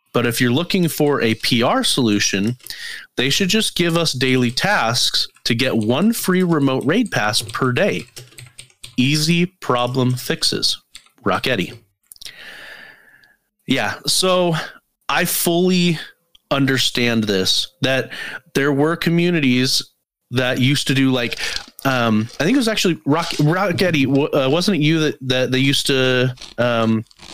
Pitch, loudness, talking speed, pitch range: 135 Hz, -18 LUFS, 130 wpm, 120-170 Hz